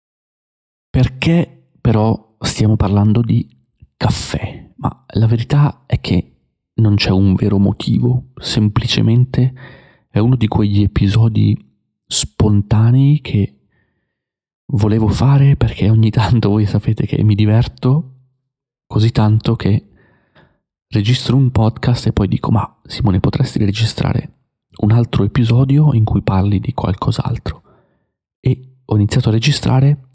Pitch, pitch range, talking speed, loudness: 115 Hz, 105-130 Hz, 120 wpm, -15 LUFS